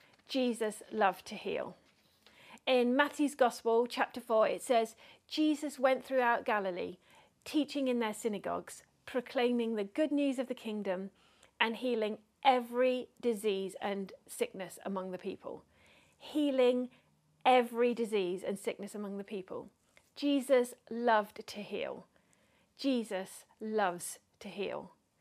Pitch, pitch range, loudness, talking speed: 235 Hz, 210-260 Hz, -34 LUFS, 120 wpm